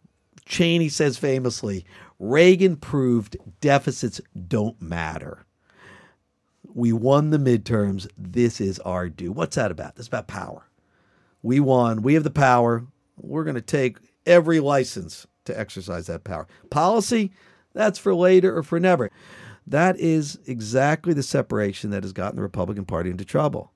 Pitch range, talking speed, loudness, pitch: 100-160 Hz, 145 wpm, -22 LUFS, 125 Hz